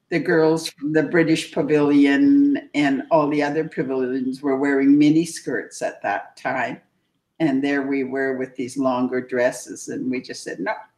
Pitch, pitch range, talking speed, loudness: 145 Hz, 130-160 Hz, 175 wpm, -21 LUFS